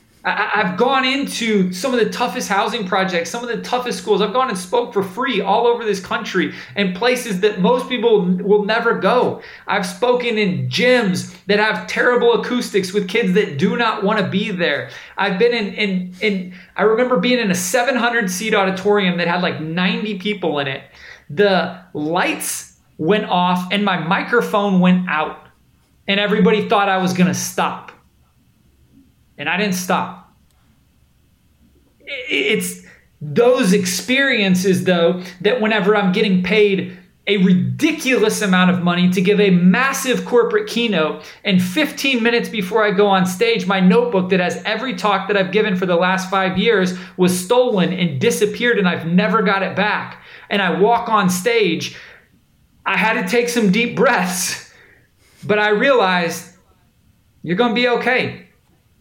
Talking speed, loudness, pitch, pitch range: 165 wpm, -17 LUFS, 205 Hz, 180-230 Hz